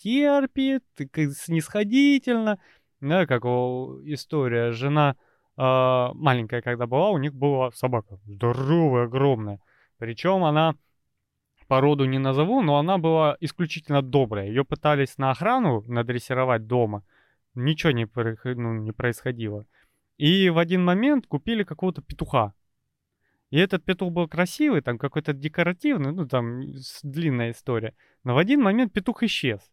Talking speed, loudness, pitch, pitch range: 125 wpm, -24 LUFS, 140 Hz, 125-170 Hz